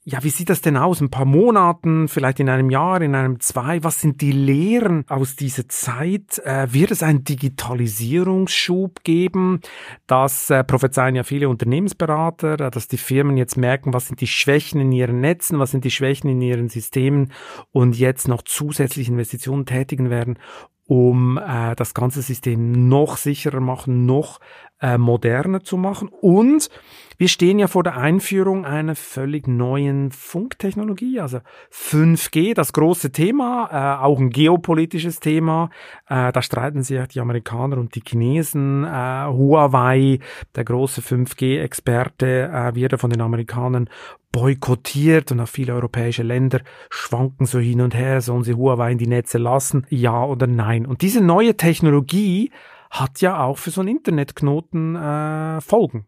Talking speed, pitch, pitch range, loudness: 160 wpm, 135 Hz, 125-160 Hz, -19 LUFS